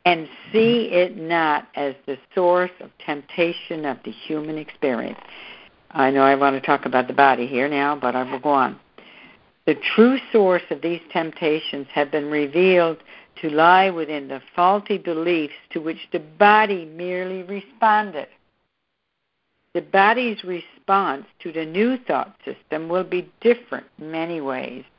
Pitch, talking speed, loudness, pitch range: 170 Hz, 155 wpm, -21 LUFS, 150-185 Hz